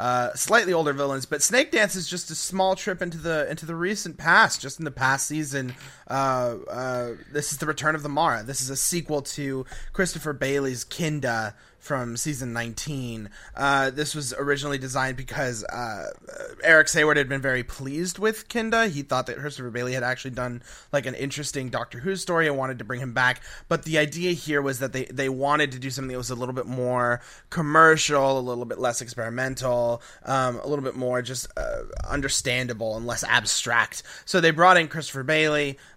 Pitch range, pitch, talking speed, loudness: 125-155 Hz, 135 Hz, 200 wpm, -24 LUFS